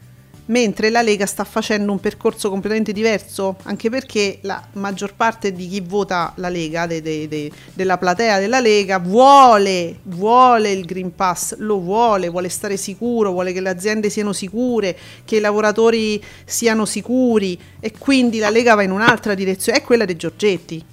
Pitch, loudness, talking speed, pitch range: 205 Hz, -17 LUFS, 170 wpm, 185-225 Hz